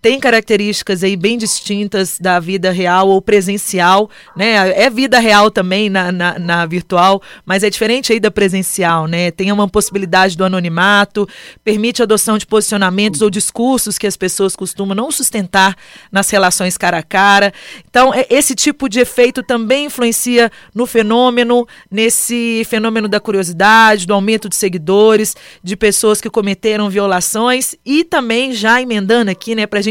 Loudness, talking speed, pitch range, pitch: -12 LUFS, 160 wpm, 190-230 Hz, 210 Hz